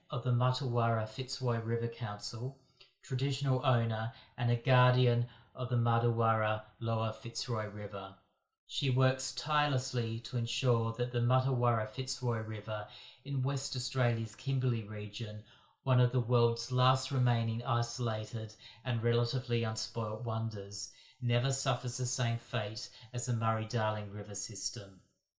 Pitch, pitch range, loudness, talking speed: 120 Hz, 110-125 Hz, -34 LUFS, 130 wpm